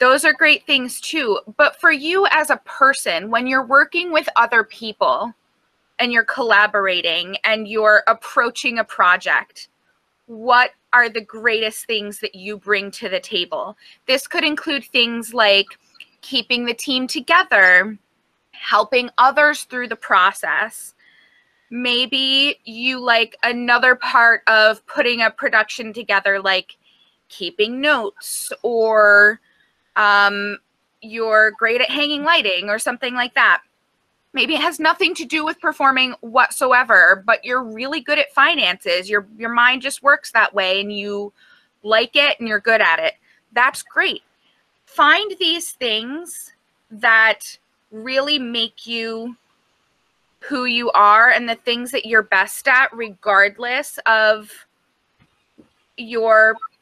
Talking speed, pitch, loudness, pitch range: 135 wpm, 240 Hz, -16 LUFS, 220-285 Hz